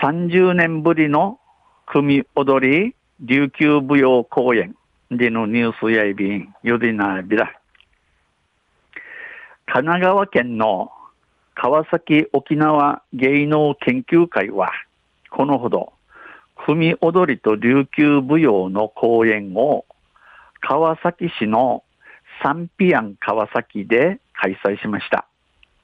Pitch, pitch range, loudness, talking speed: 140 Hz, 110-160 Hz, -18 LUFS, 180 characters per minute